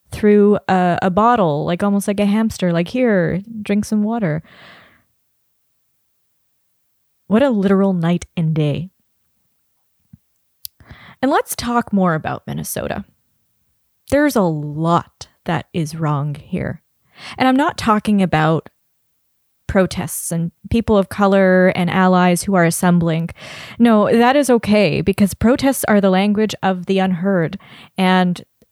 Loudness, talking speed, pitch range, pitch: -16 LUFS, 125 wpm, 170-210 Hz, 190 Hz